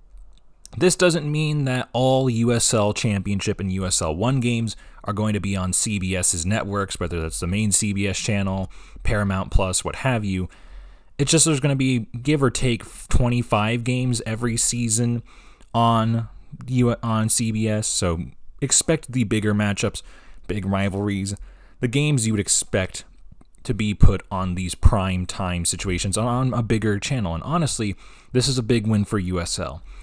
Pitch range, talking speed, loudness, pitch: 95-120 Hz, 160 wpm, -22 LUFS, 105 Hz